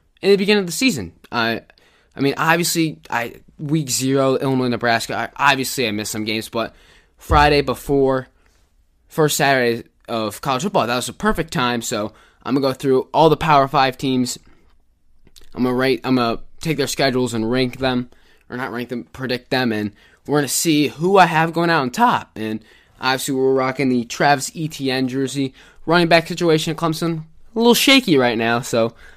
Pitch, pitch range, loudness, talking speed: 130 Hz, 120-155 Hz, -18 LUFS, 185 wpm